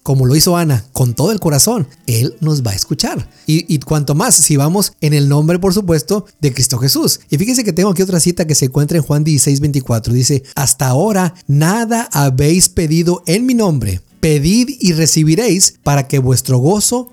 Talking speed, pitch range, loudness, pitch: 195 wpm, 140-185 Hz, -13 LUFS, 155 Hz